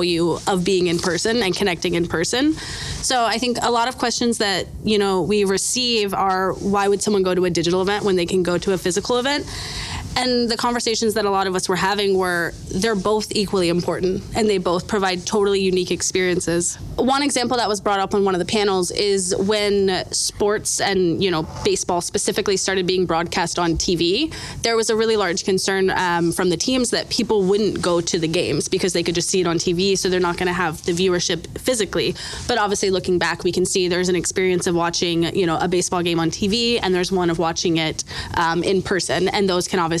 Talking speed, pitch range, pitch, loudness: 225 wpm, 180-210 Hz, 190 Hz, -20 LUFS